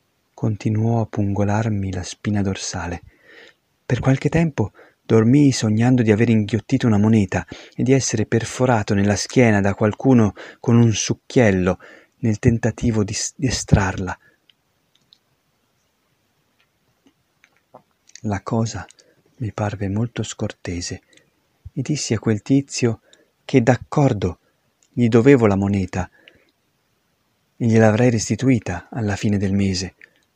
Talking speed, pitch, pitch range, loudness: 110 wpm, 110 Hz, 100-125 Hz, -19 LUFS